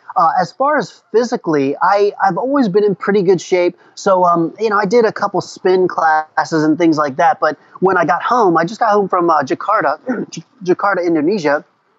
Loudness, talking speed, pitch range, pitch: -15 LUFS, 205 wpm, 170-210 Hz, 190 Hz